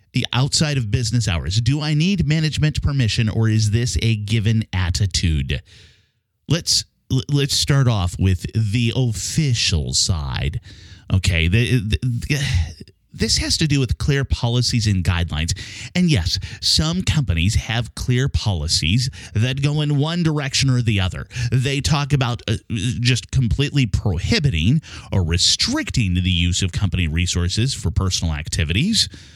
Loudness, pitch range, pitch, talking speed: -19 LUFS, 95-130 Hz, 110 Hz, 140 wpm